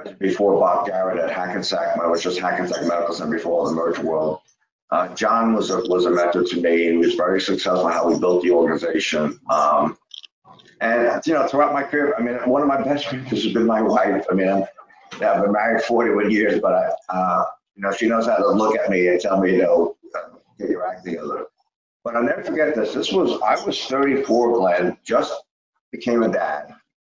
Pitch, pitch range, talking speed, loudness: 100 Hz, 90-125 Hz, 215 wpm, -20 LUFS